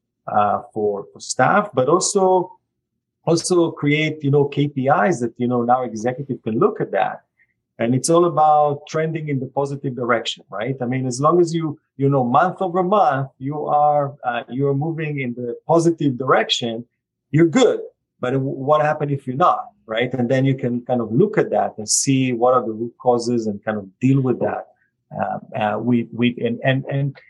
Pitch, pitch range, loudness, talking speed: 135 Hz, 120-150 Hz, -19 LUFS, 195 wpm